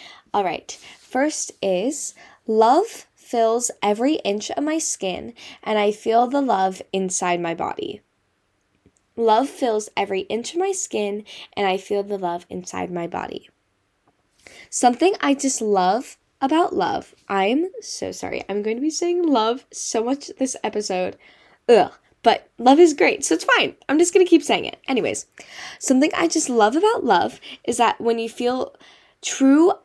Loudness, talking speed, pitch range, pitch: -21 LUFS, 165 wpm, 200-325 Hz, 245 Hz